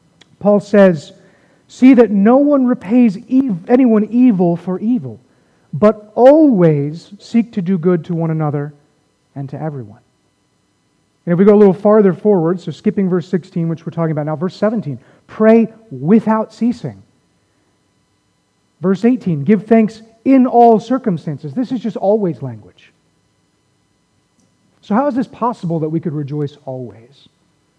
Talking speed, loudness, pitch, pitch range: 145 wpm, -14 LUFS, 190 Hz, 155-225 Hz